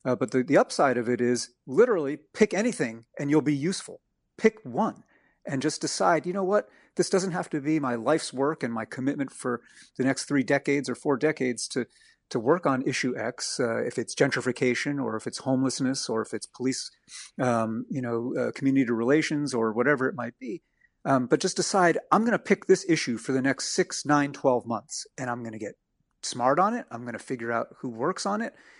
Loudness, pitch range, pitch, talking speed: -27 LUFS, 125-165 Hz, 140 Hz, 220 wpm